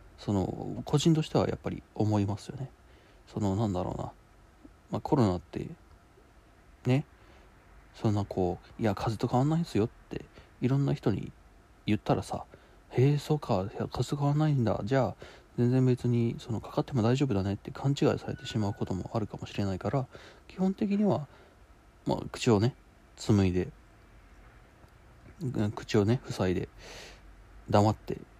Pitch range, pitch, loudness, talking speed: 100-135 Hz, 115 Hz, -30 LUFS, 270 characters per minute